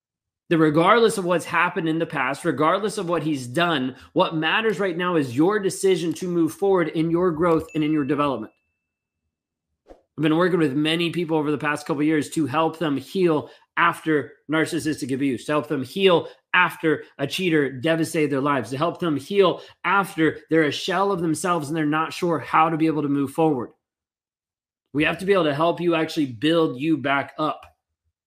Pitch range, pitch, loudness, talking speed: 150-170 Hz, 160 Hz, -22 LUFS, 195 wpm